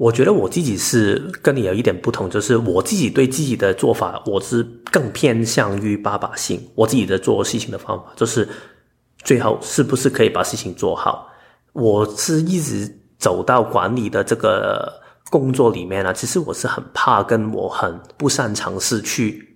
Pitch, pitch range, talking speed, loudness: 115 Hz, 105-130 Hz, 270 characters per minute, -18 LUFS